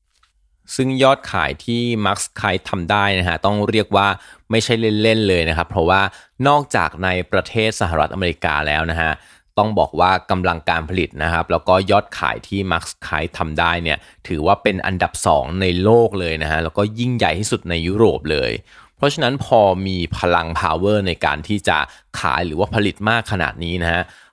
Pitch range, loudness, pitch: 85-110 Hz, -18 LUFS, 95 Hz